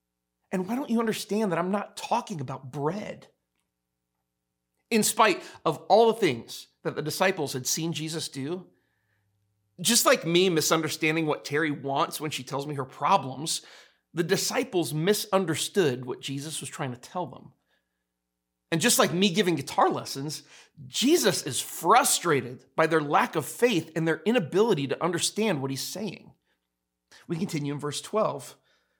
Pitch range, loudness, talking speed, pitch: 130-190 Hz, -26 LUFS, 155 wpm, 155 Hz